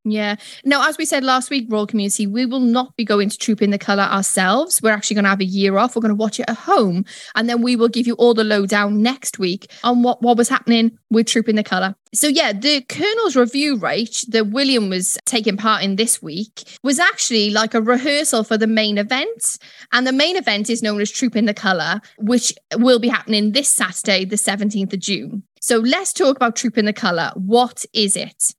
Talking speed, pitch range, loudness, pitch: 230 wpm, 205-245 Hz, -17 LUFS, 225 Hz